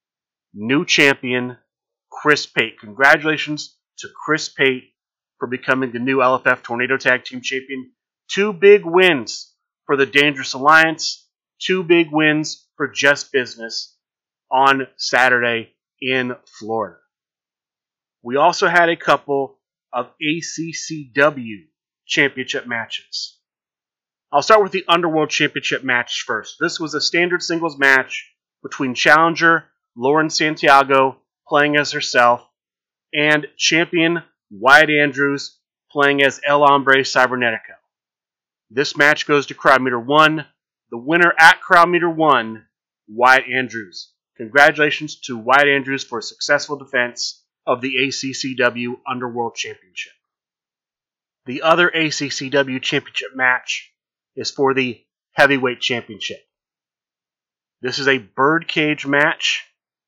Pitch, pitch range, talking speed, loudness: 140 Hz, 130-155 Hz, 115 wpm, -16 LUFS